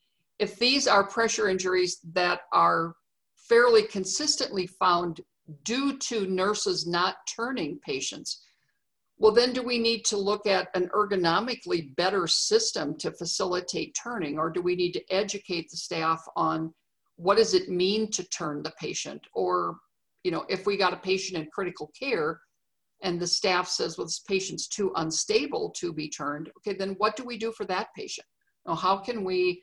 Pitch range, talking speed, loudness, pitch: 175-225 Hz, 170 wpm, -27 LUFS, 190 Hz